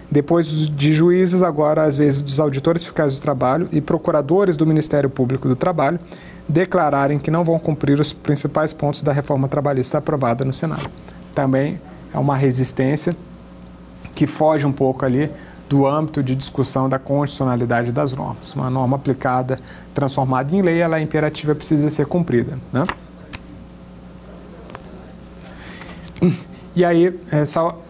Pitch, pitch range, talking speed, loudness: 150 Hz, 135-165 Hz, 140 wpm, -19 LUFS